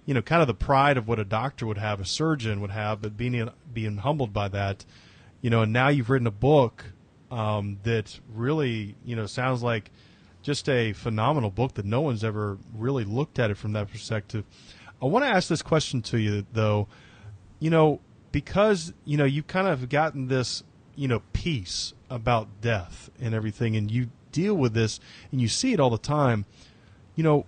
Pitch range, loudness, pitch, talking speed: 110-140 Hz, -26 LUFS, 120 Hz, 200 wpm